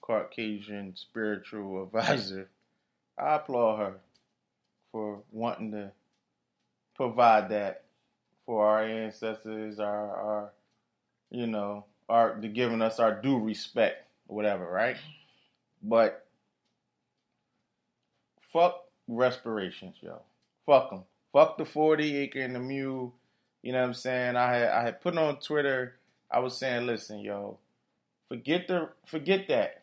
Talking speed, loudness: 125 wpm, -29 LUFS